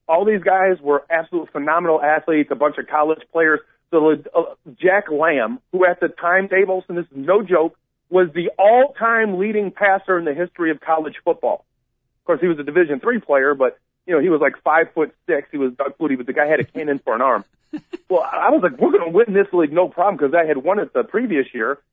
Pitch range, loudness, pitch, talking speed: 155-195 Hz, -18 LUFS, 175 Hz, 235 wpm